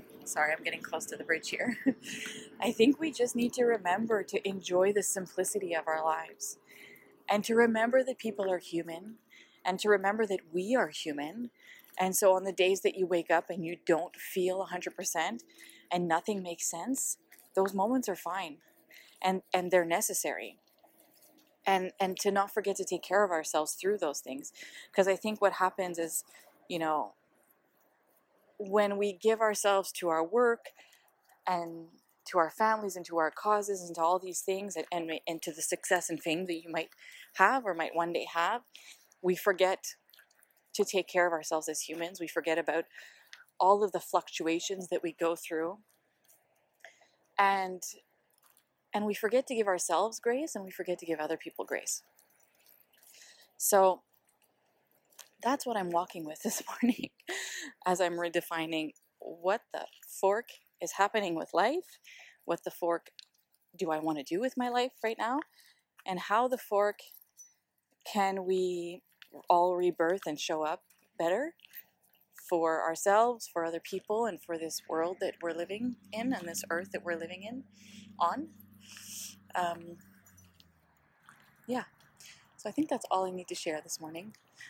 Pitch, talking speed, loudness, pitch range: 185 Hz, 165 wpm, -32 LUFS, 170-215 Hz